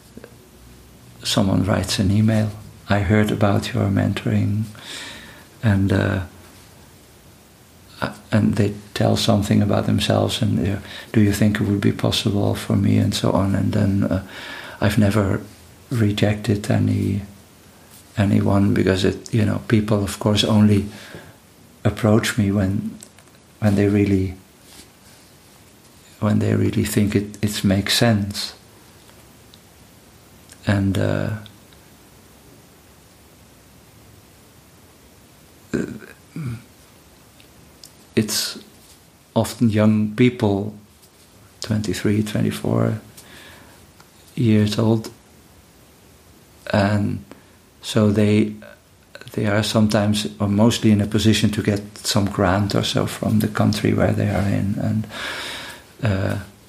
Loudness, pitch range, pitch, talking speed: -20 LUFS, 100-110 Hz, 105 Hz, 100 wpm